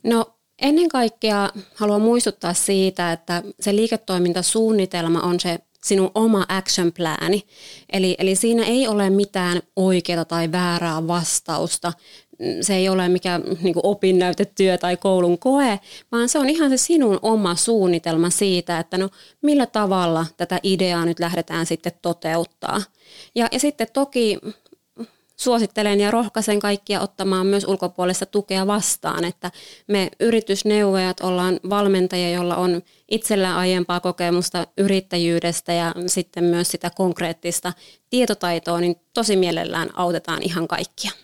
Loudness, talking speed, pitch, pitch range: -20 LUFS, 130 wpm, 185 Hz, 175-210 Hz